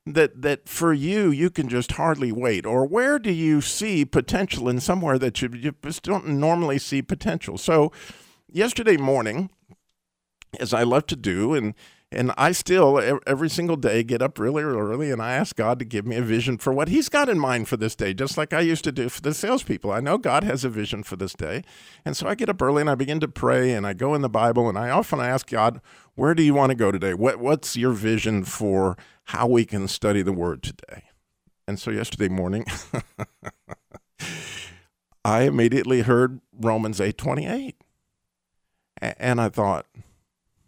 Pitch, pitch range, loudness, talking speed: 130 Hz, 110-155 Hz, -23 LUFS, 200 wpm